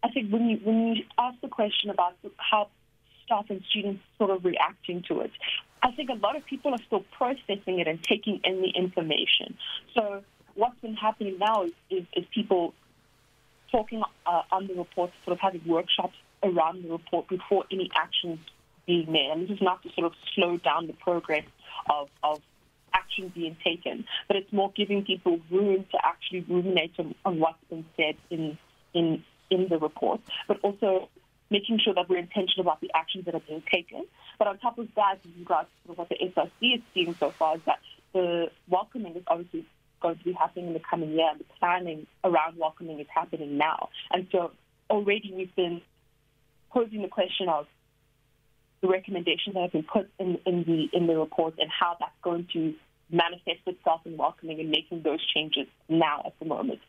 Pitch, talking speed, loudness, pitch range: 180 Hz, 195 wpm, -28 LUFS, 160-200 Hz